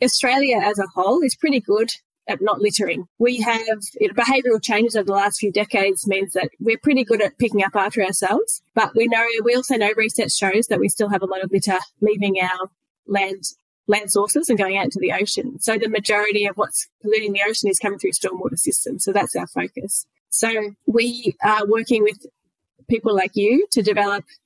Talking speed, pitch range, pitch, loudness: 210 wpm, 200-230 Hz, 210 Hz, -19 LUFS